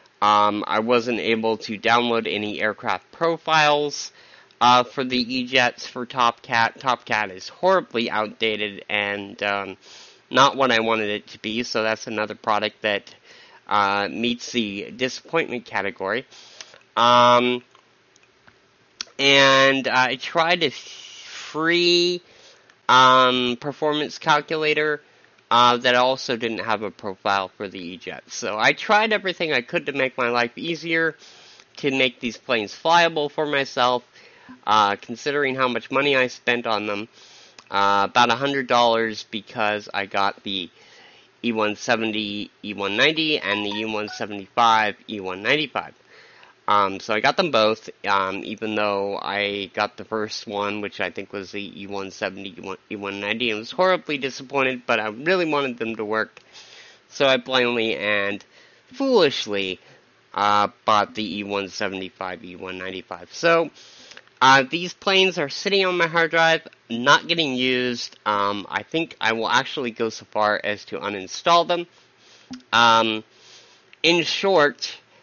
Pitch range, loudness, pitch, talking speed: 105-140 Hz, -21 LUFS, 120 Hz, 135 wpm